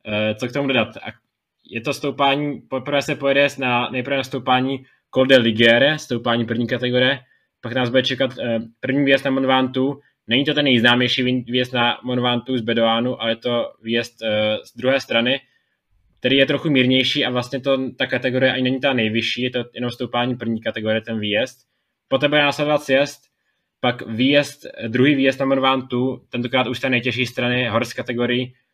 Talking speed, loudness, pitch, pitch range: 170 wpm, -19 LUFS, 125 Hz, 120-135 Hz